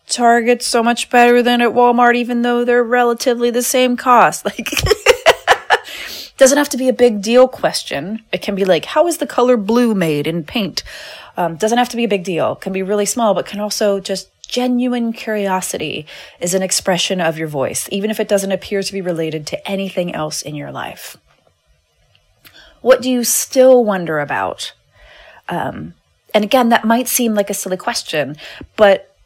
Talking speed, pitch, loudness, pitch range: 185 wpm, 225 Hz, -15 LUFS, 190-245 Hz